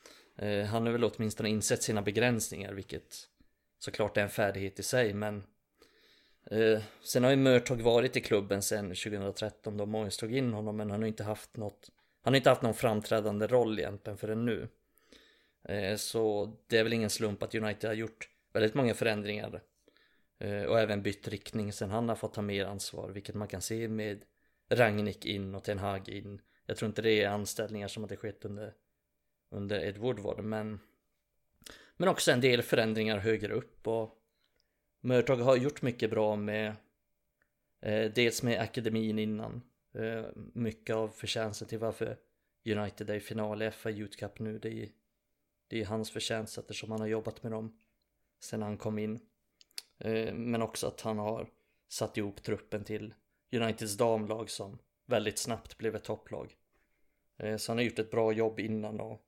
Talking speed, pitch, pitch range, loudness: 175 wpm, 110 Hz, 105-115 Hz, -33 LUFS